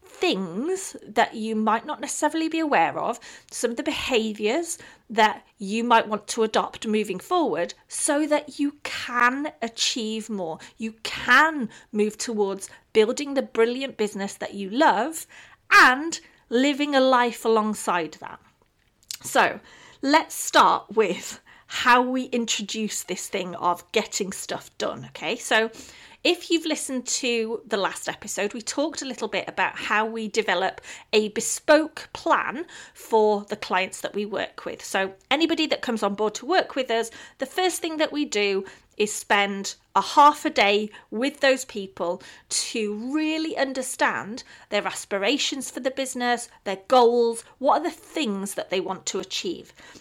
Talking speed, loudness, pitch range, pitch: 155 wpm, -24 LUFS, 210-290 Hz, 230 Hz